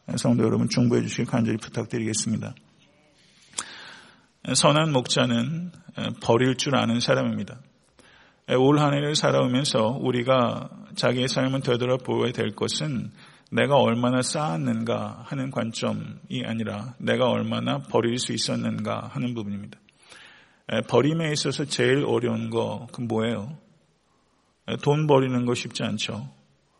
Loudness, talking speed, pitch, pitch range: -24 LUFS, 275 characters per minute, 125 Hz, 115-135 Hz